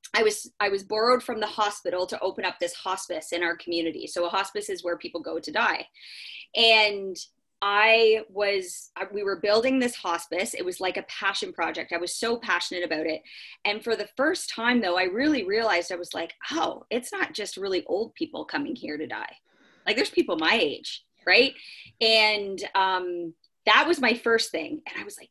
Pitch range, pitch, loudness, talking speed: 180-235 Hz, 205 Hz, -25 LUFS, 200 wpm